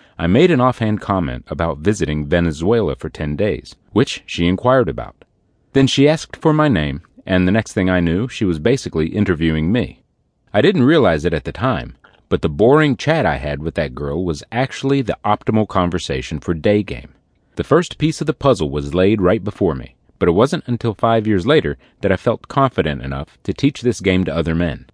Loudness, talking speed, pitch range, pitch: -17 LUFS, 205 wpm, 80-125 Hz, 95 Hz